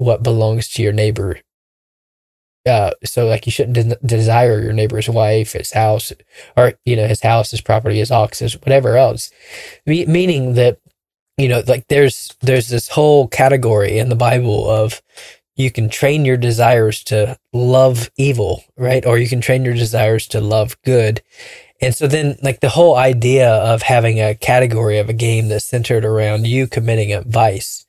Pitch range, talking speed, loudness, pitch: 110-130 Hz, 180 wpm, -14 LUFS, 120 Hz